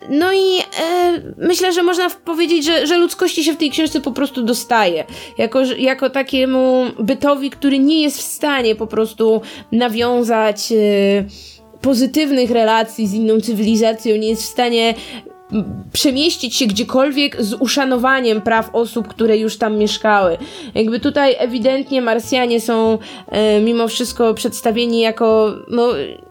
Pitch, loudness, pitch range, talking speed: 245 Hz, -16 LUFS, 225-285 Hz, 140 wpm